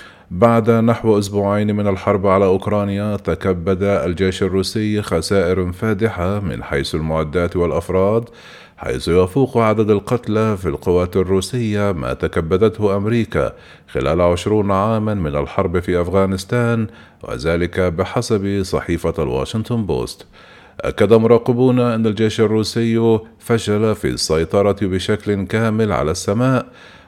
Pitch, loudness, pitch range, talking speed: 100 Hz, -17 LUFS, 95-110 Hz, 110 wpm